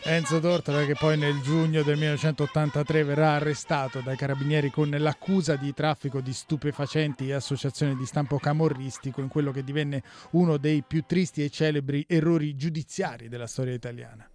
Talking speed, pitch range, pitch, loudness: 160 wpm, 140-155 Hz, 150 Hz, -27 LUFS